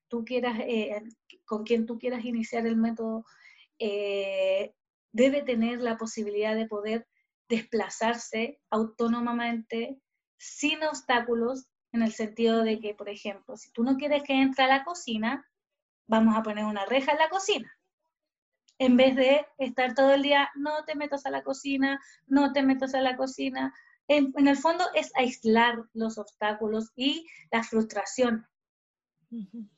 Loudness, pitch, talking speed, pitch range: -27 LUFS, 240 Hz, 150 wpm, 225-280 Hz